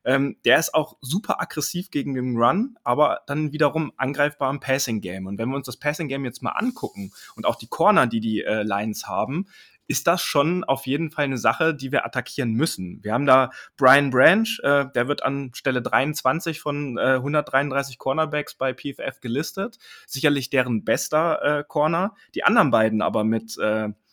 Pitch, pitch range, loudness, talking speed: 140 Hz, 125-150 Hz, -23 LUFS, 185 wpm